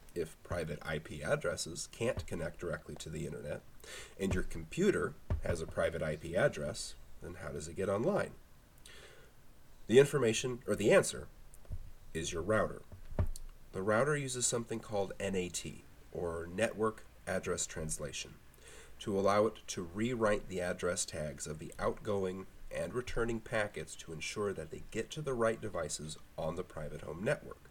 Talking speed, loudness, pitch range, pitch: 150 wpm, -36 LUFS, 85-115 Hz, 105 Hz